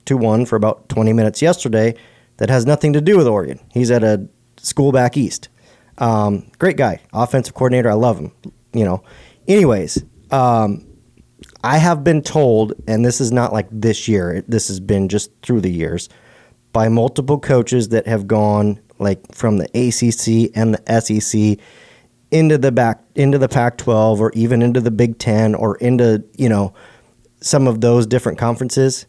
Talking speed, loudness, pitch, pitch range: 175 wpm, -16 LUFS, 115 Hz, 110-125 Hz